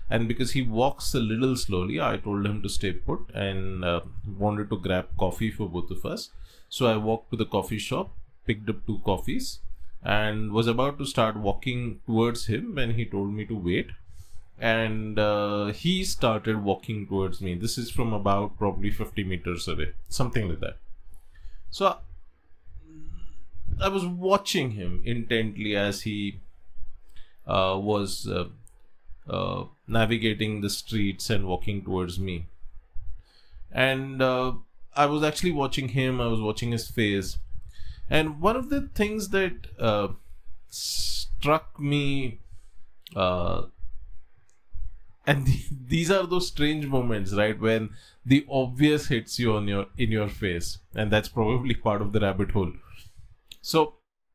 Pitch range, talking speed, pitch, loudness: 90-120 Hz, 150 wpm, 105 Hz, -27 LUFS